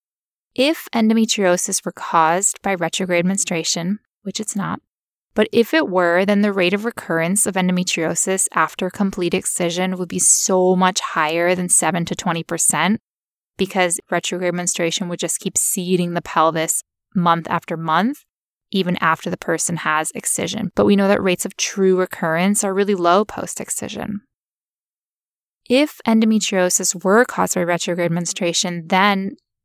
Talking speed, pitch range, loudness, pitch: 145 wpm, 175-200 Hz, -18 LUFS, 185 Hz